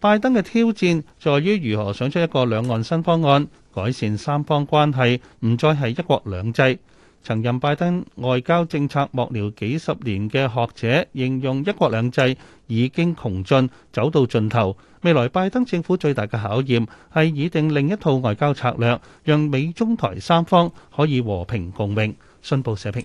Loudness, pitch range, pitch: -21 LUFS, 115-160 Hz, 135 Hz